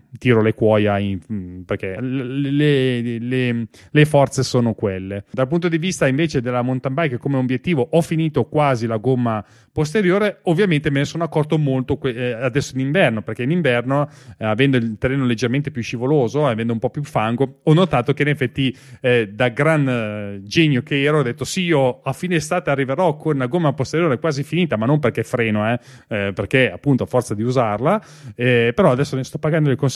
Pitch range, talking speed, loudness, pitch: 120-150 Hz, 195 wpm, -19 LUFS, 130 Hz